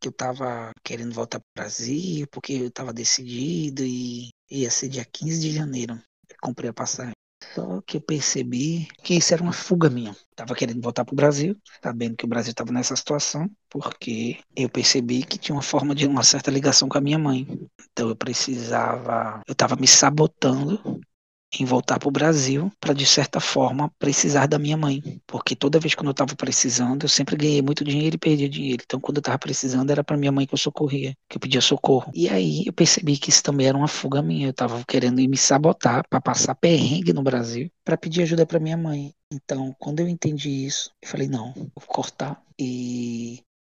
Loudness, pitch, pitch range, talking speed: -22 LUFS, 135 Hz, 125-150 Hz, 210 wpm